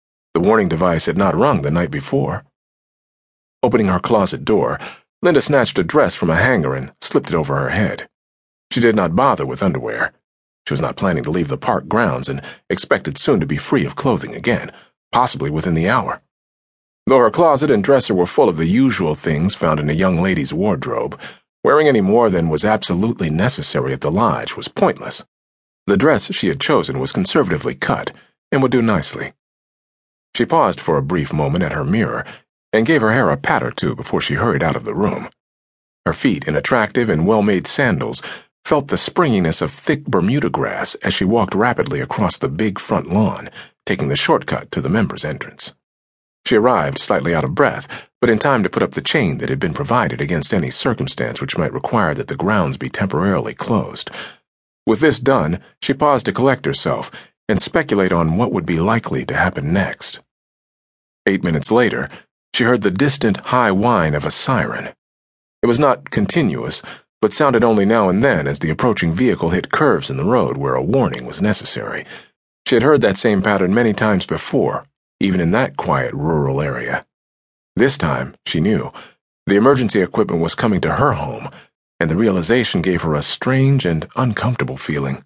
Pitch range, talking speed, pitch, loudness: 70-100 Hz, 190 wpm, 80 Hz, -17 LUFS